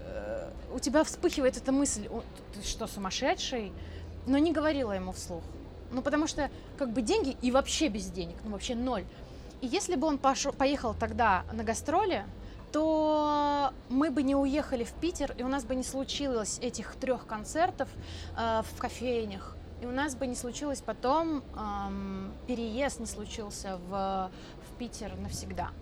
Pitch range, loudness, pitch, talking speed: 225-290 Hz, -32 LUFS, 260 Hz, 165 wpm